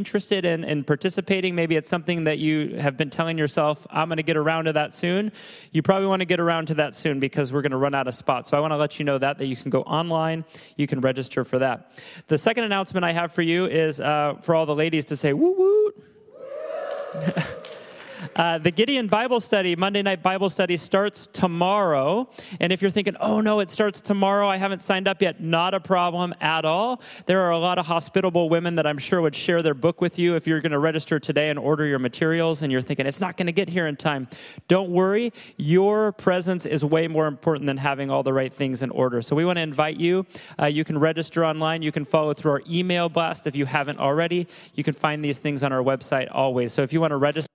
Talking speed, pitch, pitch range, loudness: 245 wpm, 165 Hz, 150-185 Hz, -23 LUFS